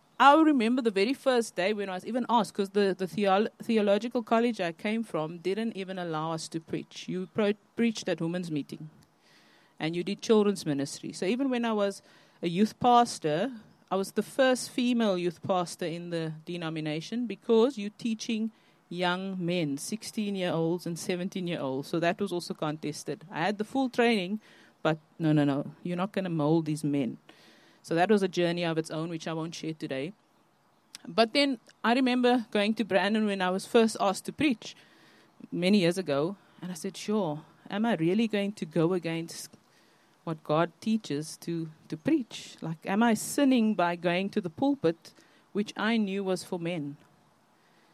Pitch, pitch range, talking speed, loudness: 190 Hz, 165-220 Hz, 190 wpm, -29 LUFS